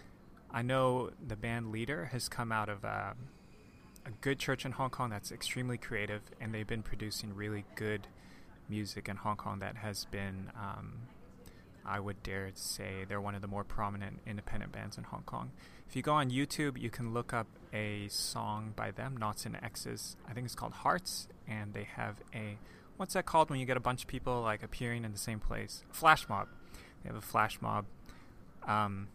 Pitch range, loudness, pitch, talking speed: 100-125 Hz, -37 LUFS, 110 Hz, 200 wpm